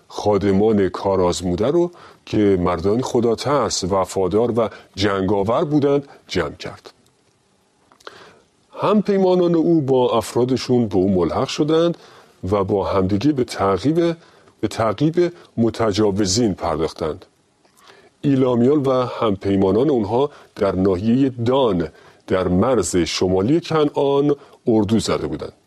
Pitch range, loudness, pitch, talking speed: 100-145 Hz, -19 LUFS, 120 Hz, 105 wpm